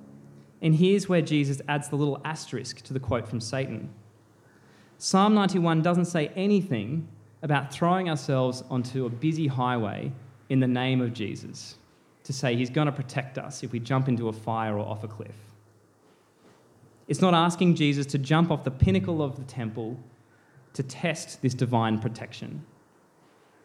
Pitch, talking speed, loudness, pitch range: 130 Hz, 160 wpm, -27 LUFS, 115-155 Hz